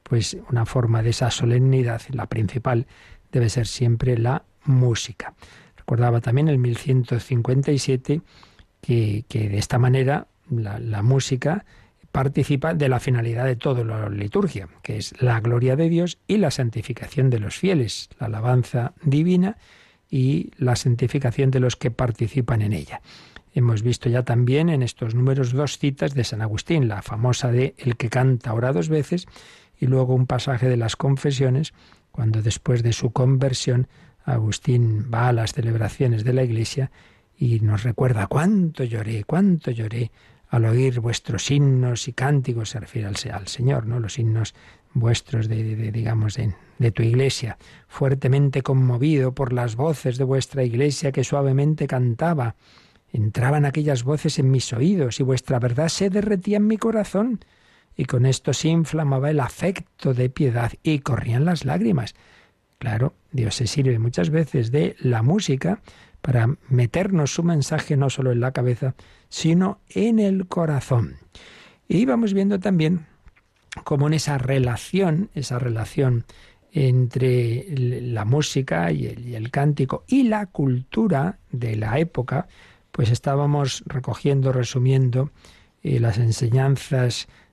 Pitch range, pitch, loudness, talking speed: 120-145 Hz, 130 Hz, -22 LUFS, 150 wpm